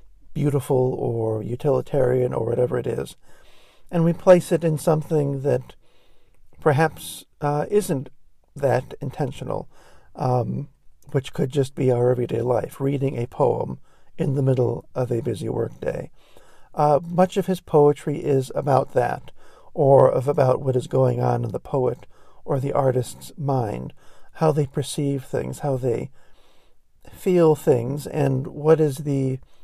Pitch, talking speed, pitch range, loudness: 140 Hz, 145 wpm, 125-150 Hz, -22 LUFS